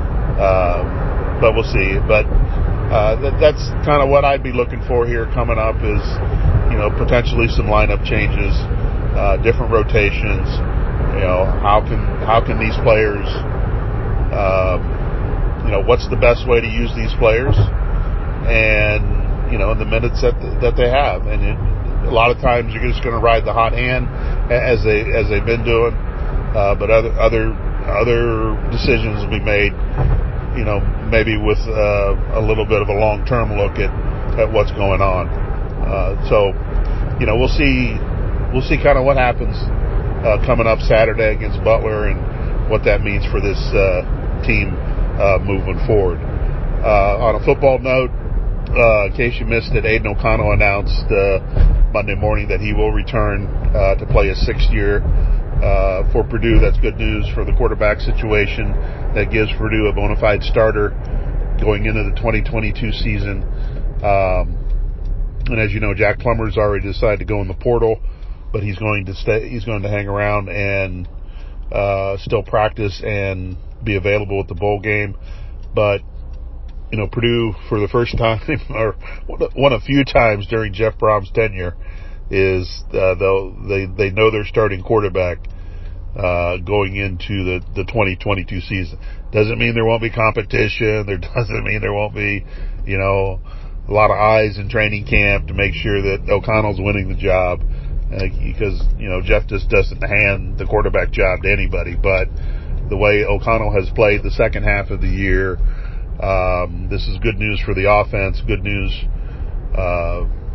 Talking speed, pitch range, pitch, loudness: 170 wpm, 95-110 Hz, 105 Hz, -17 LUFS